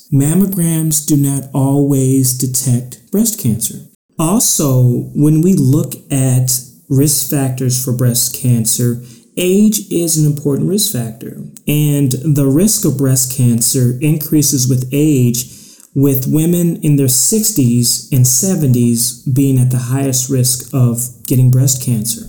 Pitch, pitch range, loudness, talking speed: 135 Hz, 125-150 Hz, -13 LUFS, 130 wpm